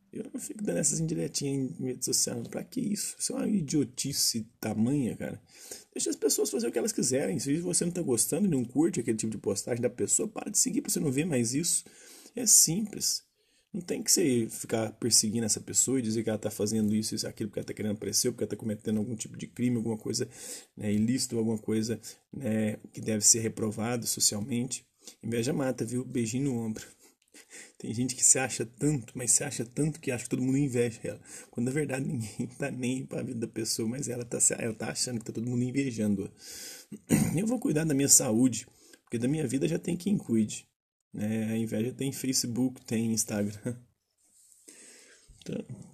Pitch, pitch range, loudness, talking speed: 125 Hz, 110-145 Hz, -29 LUFS, 210 wpm